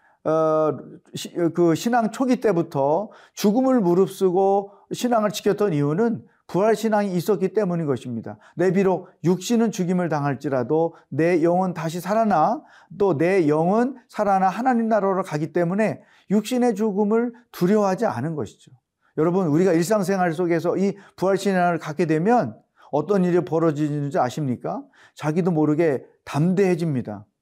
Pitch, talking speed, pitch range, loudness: 185 Hz, 315 characters per minute, 160-210 Hz, -22 LUFS